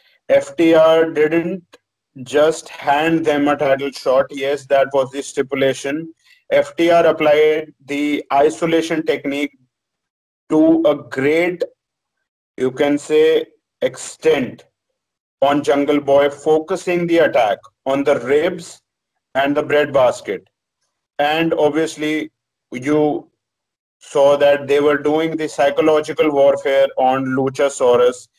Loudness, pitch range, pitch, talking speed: -16 LUFS, 140-165 Hz, 150 Hz, 105 wpm